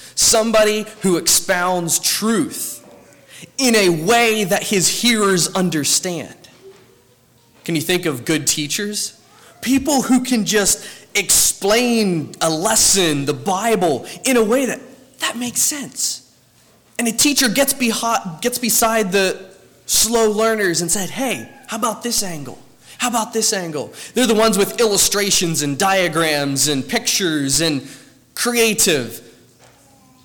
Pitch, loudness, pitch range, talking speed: 205 Hz, -16 LUFS, 165-230 Hz, 130 wpm